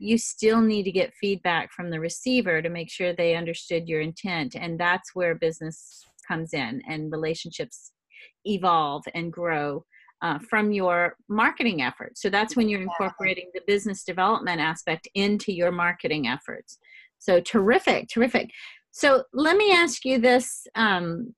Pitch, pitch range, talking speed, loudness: 190 Hz, 170-225 Hz, 155 wpm, -24 LUFS